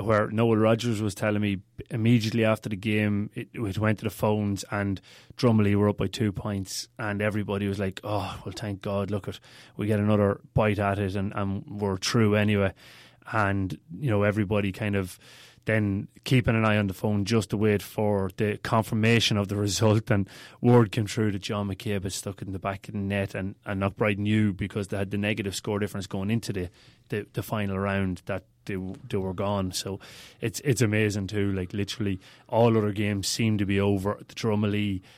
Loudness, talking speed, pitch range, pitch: -27 LUFS, 205 wpm, 100-110 Hz, 105 Hz